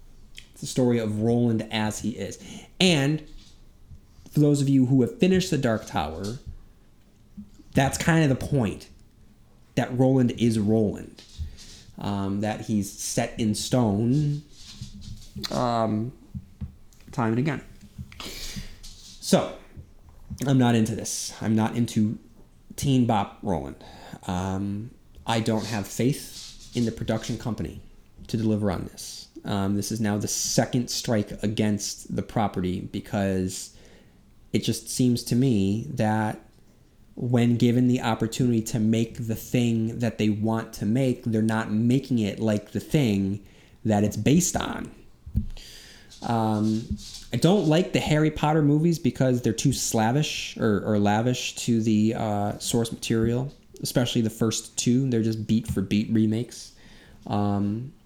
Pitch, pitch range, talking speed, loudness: 110 Hz, 105-125 Hz, 140 wpm, -25 LUFS